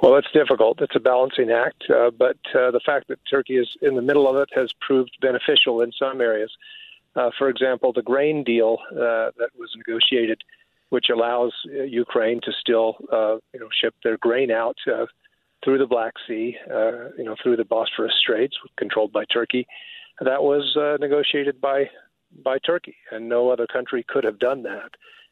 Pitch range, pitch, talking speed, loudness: 120-165 Hz, 135 Hz, 185 wpm, -21 LUFS